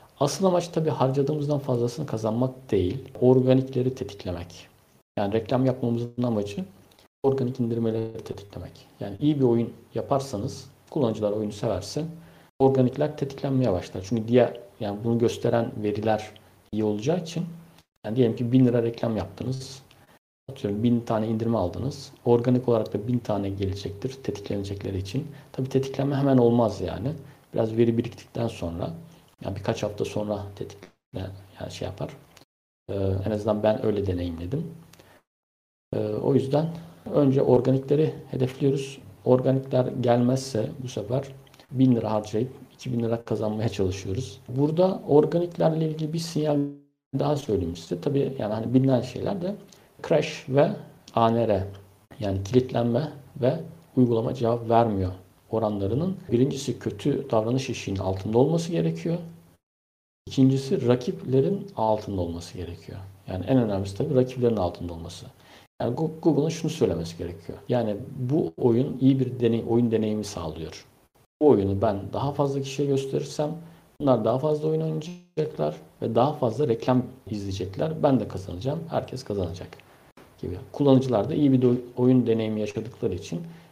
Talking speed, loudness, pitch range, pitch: 135 wpm, -26 LUFS, 105-135 Hz, 125 Hz